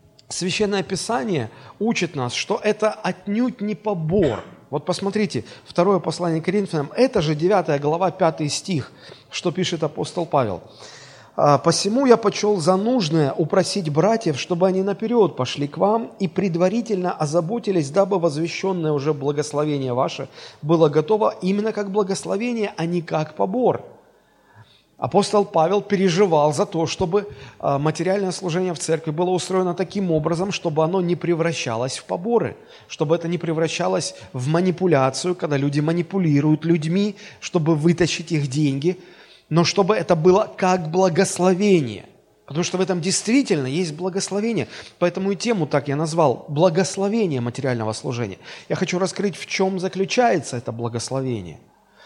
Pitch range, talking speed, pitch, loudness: 150-195 Hz, 135 wpm, 175 Hz, -21 LUFS